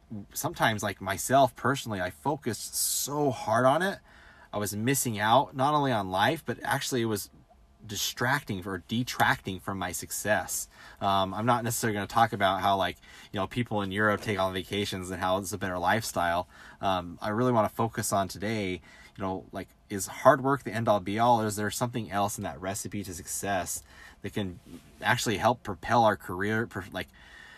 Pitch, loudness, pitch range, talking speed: 105 Hz, -29 LUFS, 95-115 Hz, 195 wpm